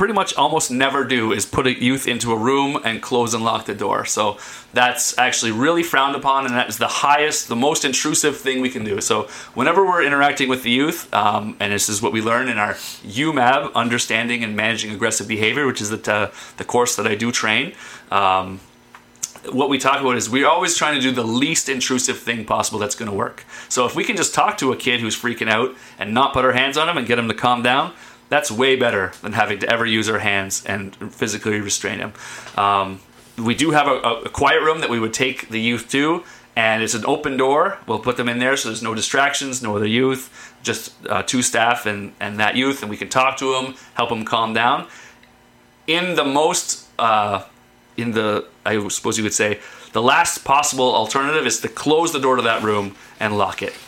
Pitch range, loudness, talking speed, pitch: 110-135 Hz, -19 LUFS, 225 wpm, 120 Hz